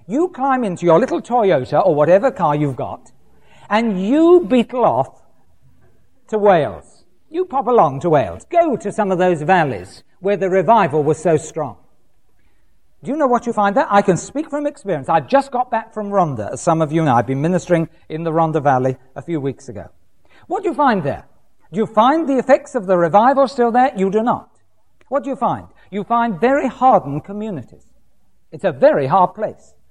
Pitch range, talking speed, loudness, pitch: 155-255 Hz, 200 wpm, -17 LUFS, 200 Hz